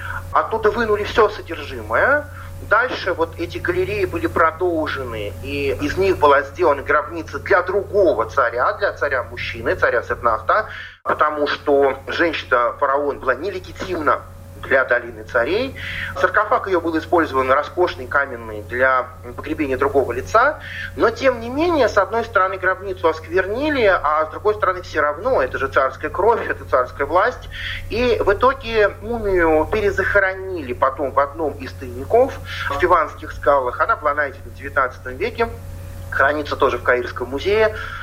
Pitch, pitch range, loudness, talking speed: 185 Hz, 135-225 Hz, -19 LUFS, 140 wpm